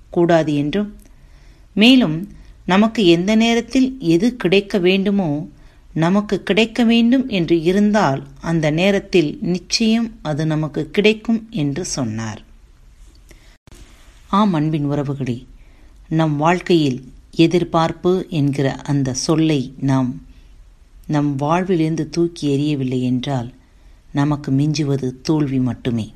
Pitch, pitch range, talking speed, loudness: 160 Hz, 135-190 Hz, 95 wpm, -18 LUFS